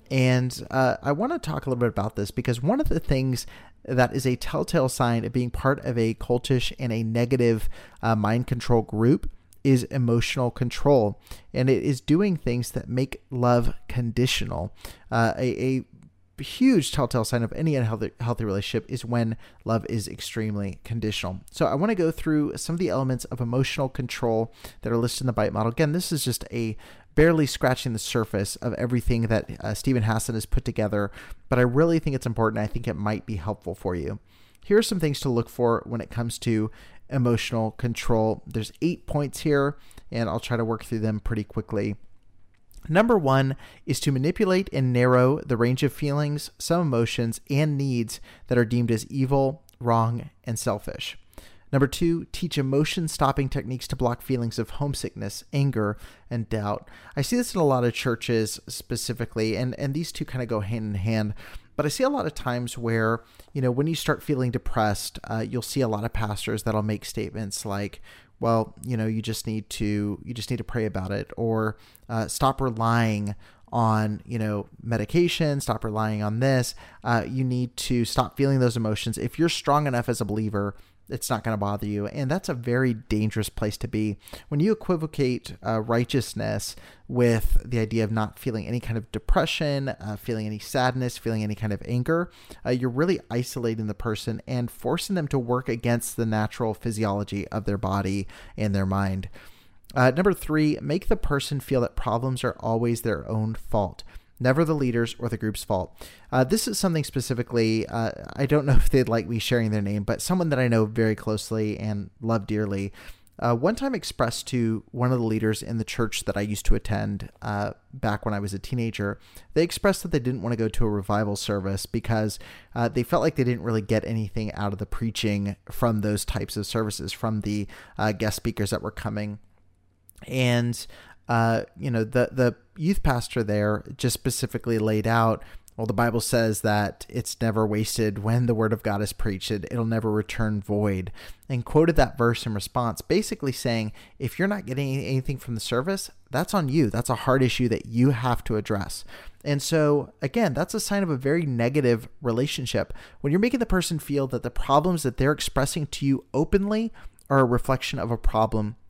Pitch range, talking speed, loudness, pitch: 110-130 Hz, 200 wpm, -26 LUFS, 115 Hz